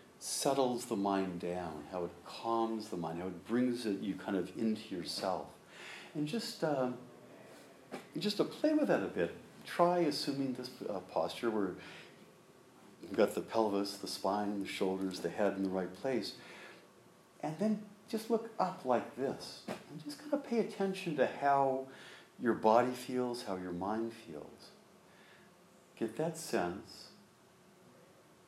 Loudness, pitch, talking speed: -36 LUFS, 120 Hz, 155 wpm